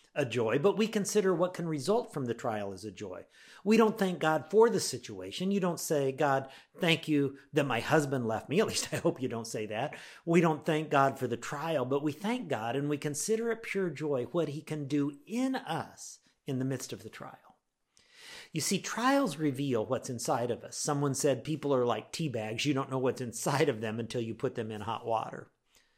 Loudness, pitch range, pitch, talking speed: -31 LUFS, 125-175 Hz, 145 Hz, 225 wpm